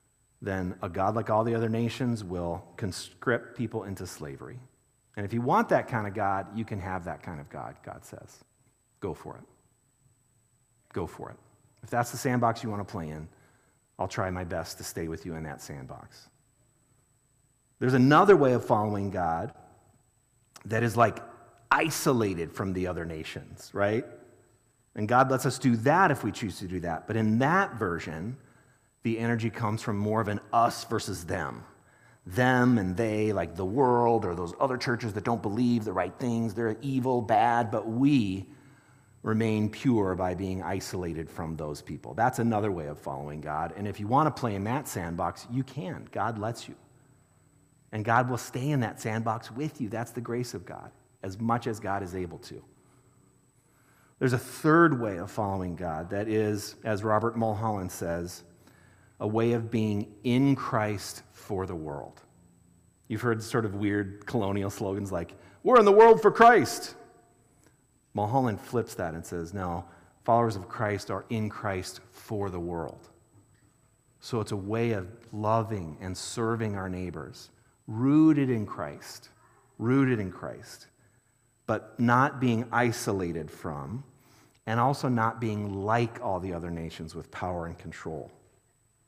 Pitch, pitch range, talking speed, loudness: 110 Hz, 95-120 Hz, 170 wpm, -28 LUFS